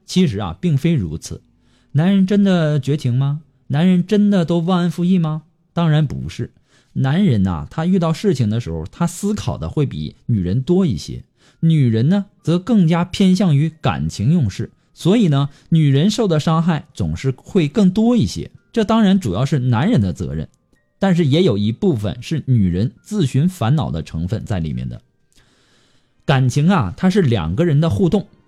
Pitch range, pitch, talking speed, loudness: 125-185 Hz, 155 Hz, 255 characters per minute, -17 LUFS